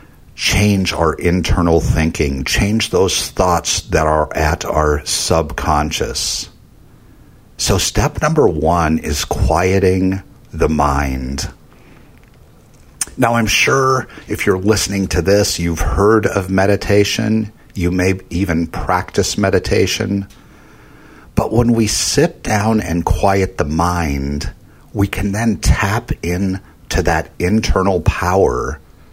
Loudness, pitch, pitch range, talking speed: -16 LUFS, 95 Hz, 80-100 Hz, 110 wpm